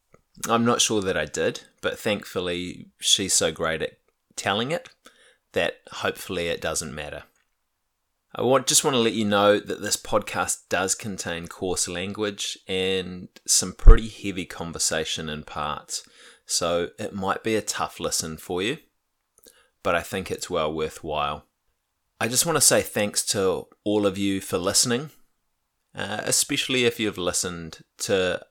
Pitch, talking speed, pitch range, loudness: 100 Hz, 150 wpm, 90-115 Hz, -24 LUFS